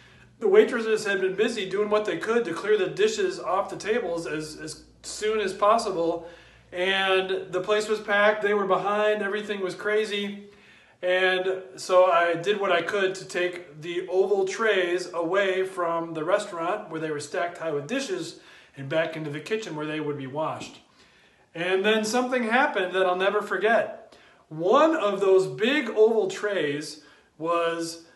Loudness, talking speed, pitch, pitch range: -25 LUFS, 170 wpm, 195 Hz, 170-215 Hz